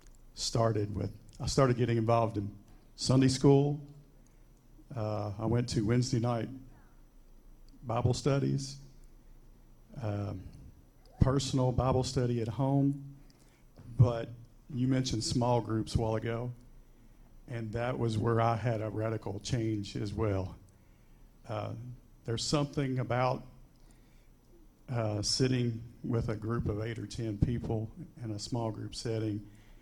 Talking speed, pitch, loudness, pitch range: 125 wpm, 115 Hz, -32 LUFS, 110-130 Hz